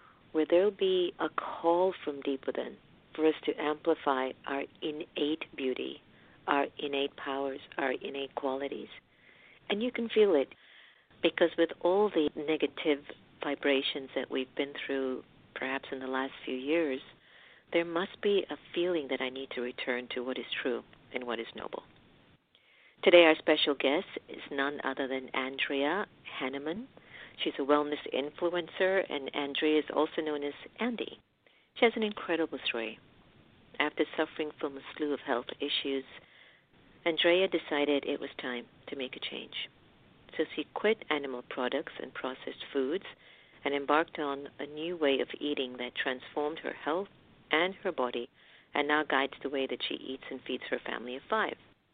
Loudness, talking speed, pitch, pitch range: -32 LUFS, 165 wpm, 145 Hz, 135-165 Hz